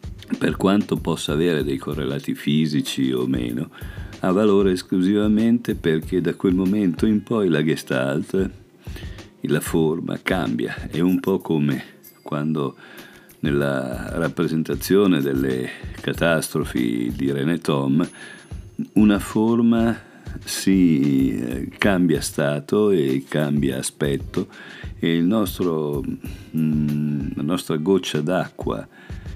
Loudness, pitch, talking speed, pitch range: -21 LUFS, 80 Hz, 100 wpm, 70-95 Hz